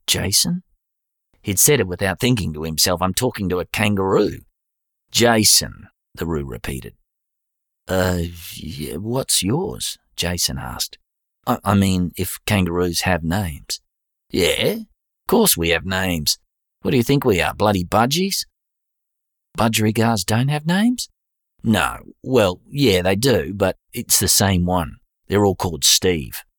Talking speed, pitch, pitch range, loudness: 140 wpm, 95 Hz, 90-115 Hz, -19 LUFS